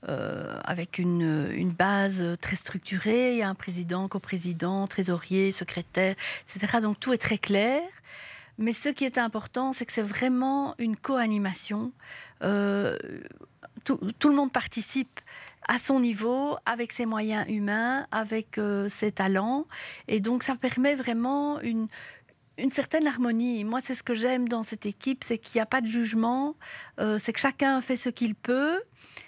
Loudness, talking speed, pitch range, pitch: -28 LUFS, 165 wpm, 200-255 Hz, 230 Hz